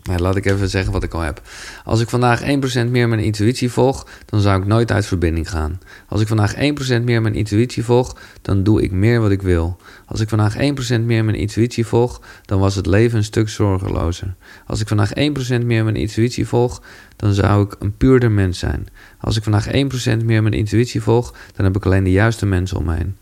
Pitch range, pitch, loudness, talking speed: 95-115 Hz, 105 Hz, -18 LUFS, 225 wpm